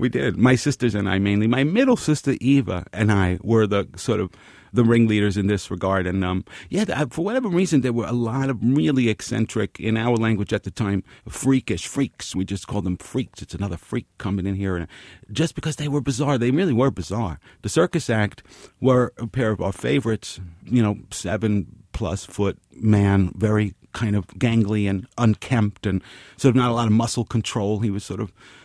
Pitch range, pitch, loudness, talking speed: 100-125 Hz, 110 Hz, -22 LUFS, 205 wpm